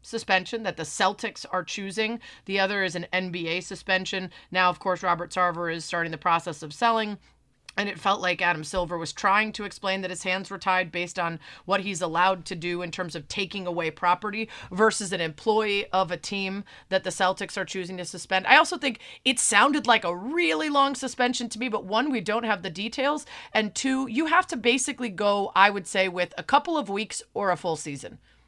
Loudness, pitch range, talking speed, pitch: -25 LUFS, 180-220 Hz, 215 wpm, 195 Hz